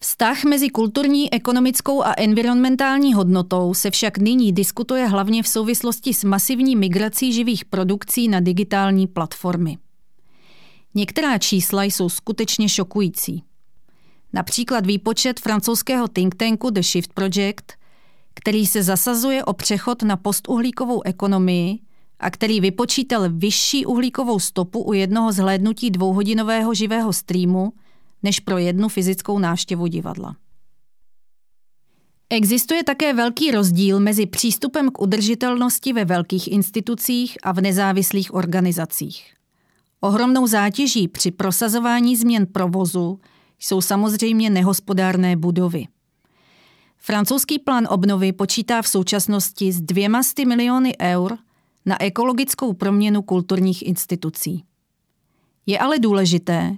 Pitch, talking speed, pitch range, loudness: 205 Hz, 110 wpm, 190-235 Hz, -19 LUFS